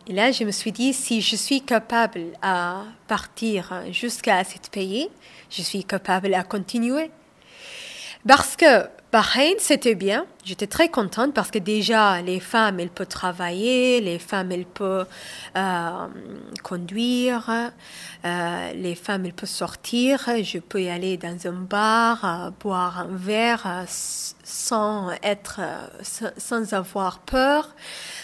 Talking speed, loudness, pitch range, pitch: 140 wpm, -23 LUFS, 185-235 Hz, 205 Hz